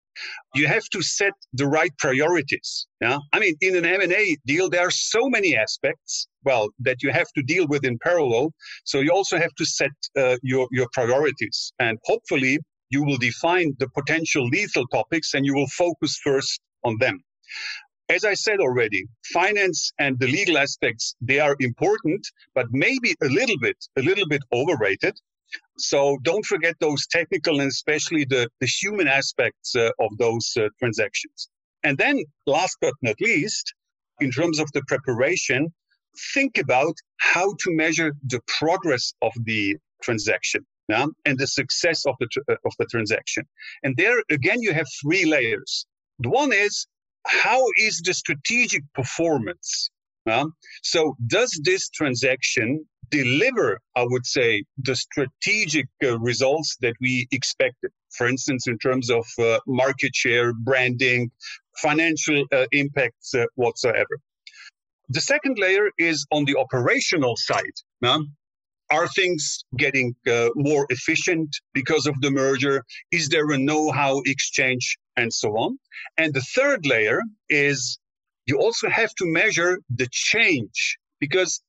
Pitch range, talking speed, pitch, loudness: 130-185 Hz, 155 wpm, 150 Hz, -22 LUFS